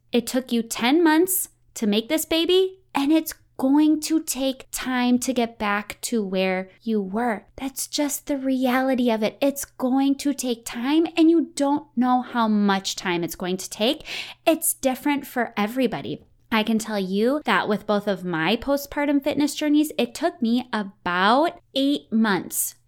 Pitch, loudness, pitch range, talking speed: 250 Hz, -23 LUFS, 215-290 Hz, 175 wpm